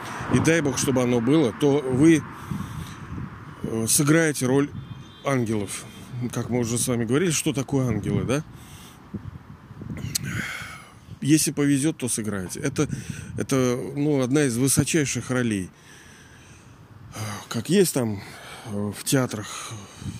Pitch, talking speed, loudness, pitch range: 130 Hz, 110 wpm, -24 LUFS, 115-145 Hz